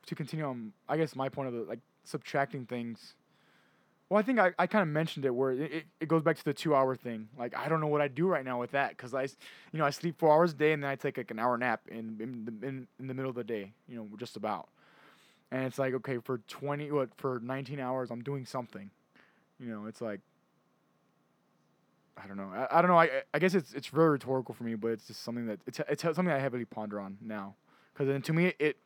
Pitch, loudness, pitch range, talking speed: 135 Hz, -32 LUFS, 120-150 Hz, 260 wpm